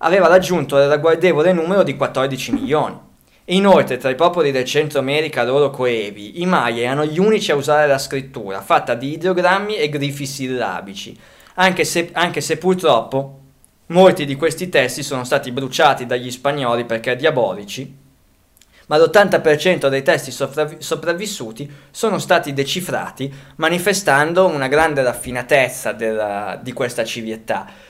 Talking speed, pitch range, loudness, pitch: 140 wpm, 130-170 Hz, -17 LUFS, 145 Hz